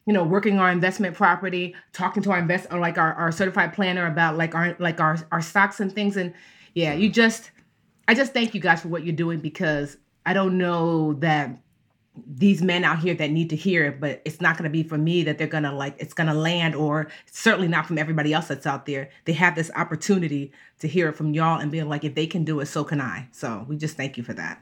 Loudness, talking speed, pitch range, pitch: -23 LUFS, 250 wpm, 155-180 Hz, 165 Hz